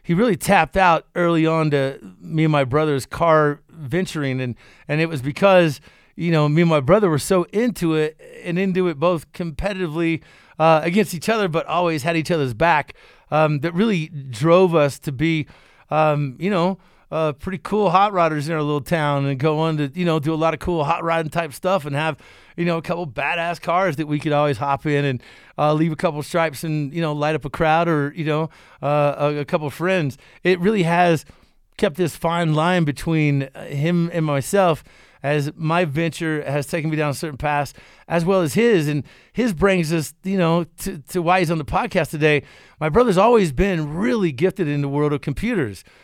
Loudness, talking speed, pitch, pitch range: -20 LUFS, 210 wpm, 160 Hz, 150-175 Hz